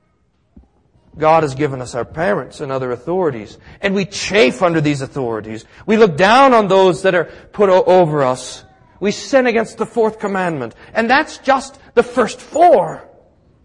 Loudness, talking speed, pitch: -15 LUFS, 165 wpm, 185 Hz